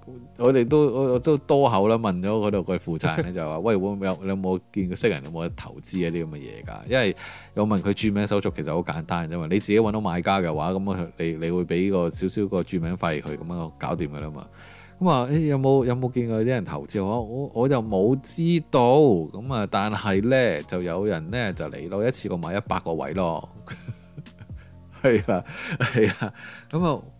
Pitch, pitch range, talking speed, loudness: 100 Hz, 90-120 Hz, 290 characters per minute, -24 LUFS